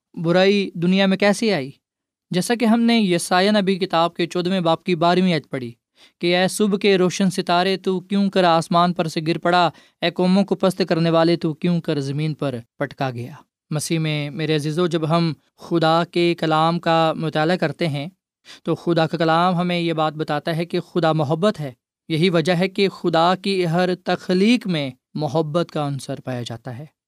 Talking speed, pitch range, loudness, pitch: 195 wpm, 155-185 Hz, -20 LUFS, 170 Hz